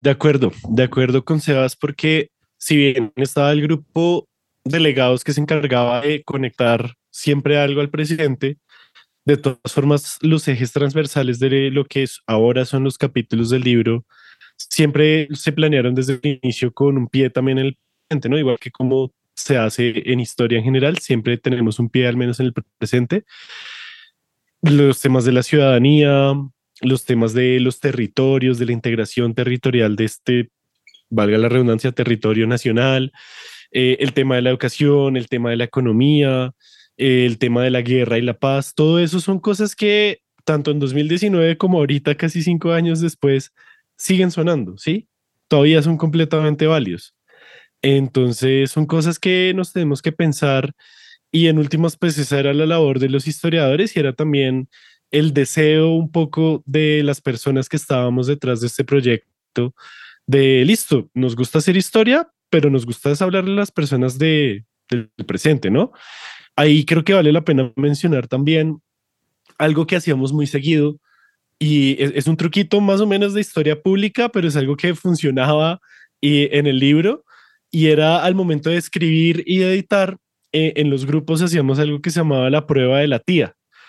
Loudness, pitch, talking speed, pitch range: -17 LUFS, 145 Hz, 170 wpm, 130-160 Hz